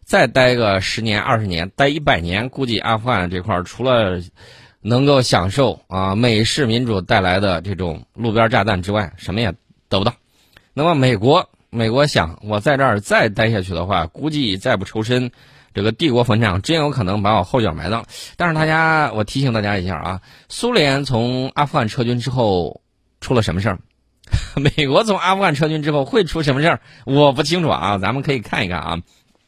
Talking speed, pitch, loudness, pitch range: 295 characters per minute, 115 Hz, -17 LUFS, 100-140 Hz